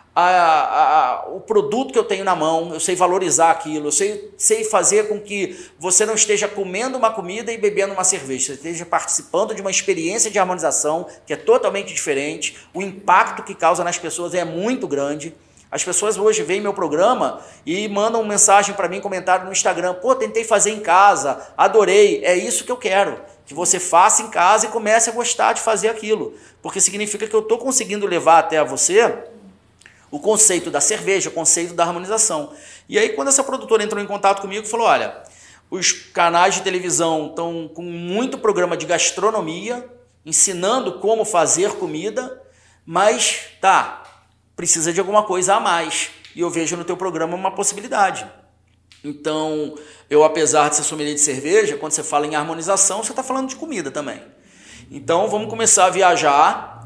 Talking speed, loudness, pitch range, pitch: 180 wpm, -17 LUFS, 170-220 Hz, 195 Hz